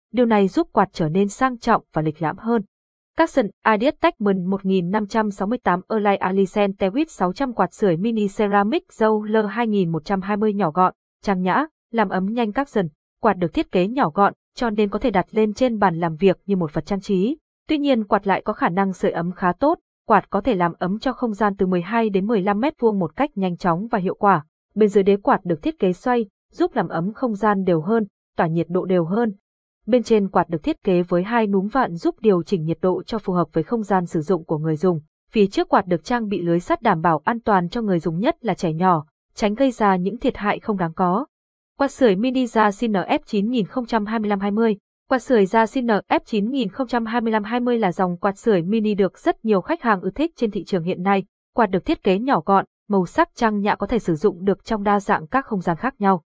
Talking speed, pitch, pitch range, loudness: 230 wpm, 205 Hz, 185-235 Hz, -21 LUFS